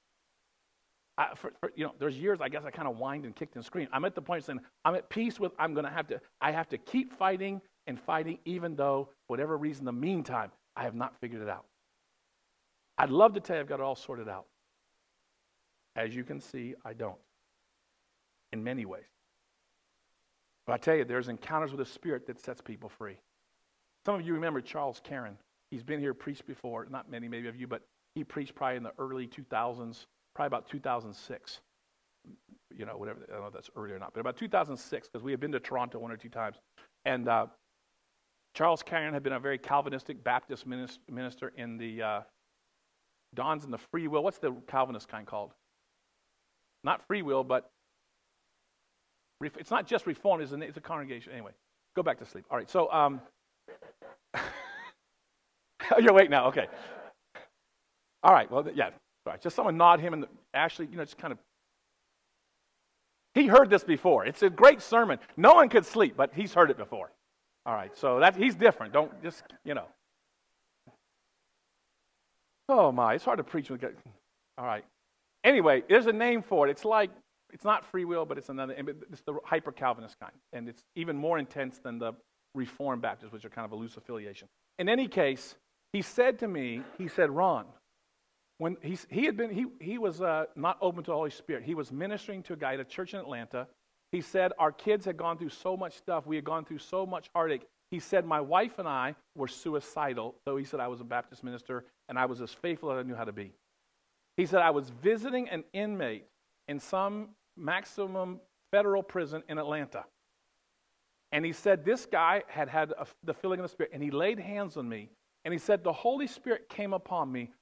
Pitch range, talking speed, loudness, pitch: 125-185 Hz, 205 wpm, -30 LUFS, 155 Hz